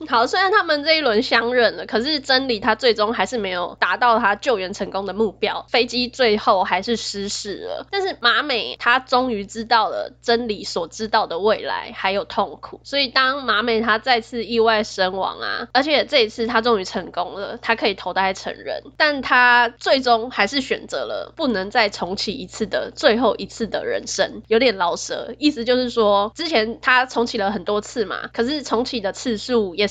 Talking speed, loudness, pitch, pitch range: 290 characters per minute, -20 LUFS, 230 Hz, 210-250 Hz